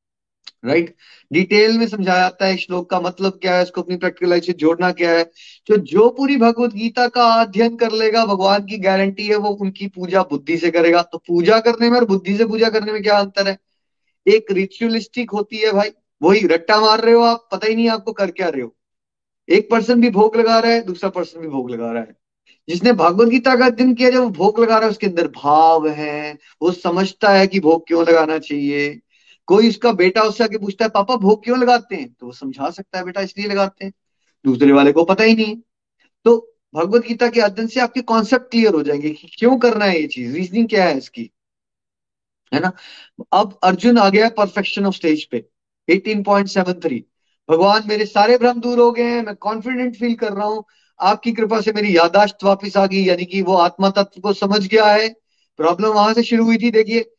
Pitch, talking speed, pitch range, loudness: 200 Hz, 215 wpm, 175-225 Hz, -16 LUFS